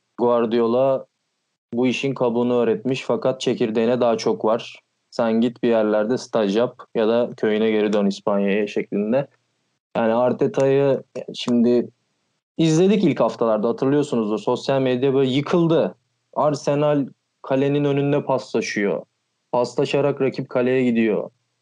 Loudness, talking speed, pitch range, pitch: -20 LUFS, 115 wpm, 115-140 Hz, 125 Hz